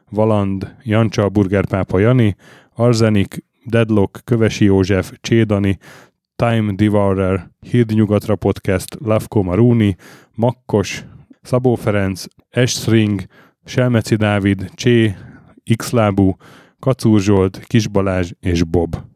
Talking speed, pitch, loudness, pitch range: 90 wpm, 105 Hz, -16 LUFS, 100-115 Hz